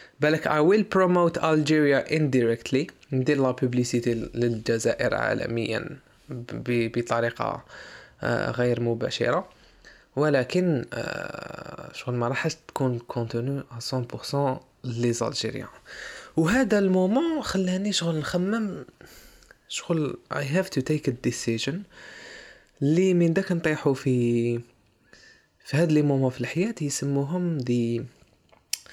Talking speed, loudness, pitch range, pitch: 105 wpm, -25 LUFS, 120-170 Hz, 140 Hz